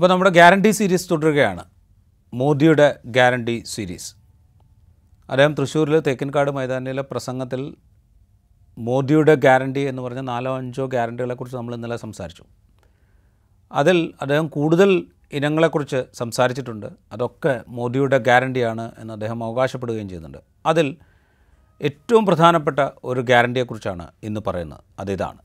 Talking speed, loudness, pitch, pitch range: 100 wpm, -19 LUFS, 125 Hz, 100-145 Hz